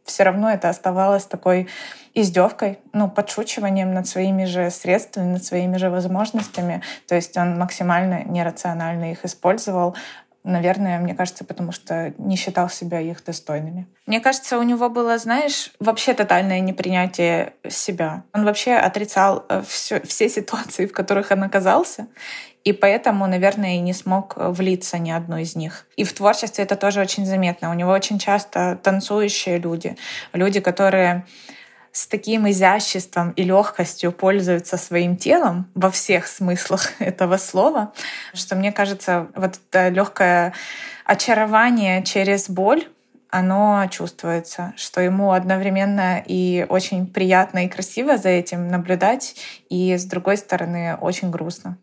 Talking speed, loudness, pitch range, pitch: 140 wpm, -20 LUFS, 180-205 Hz, 190 Hz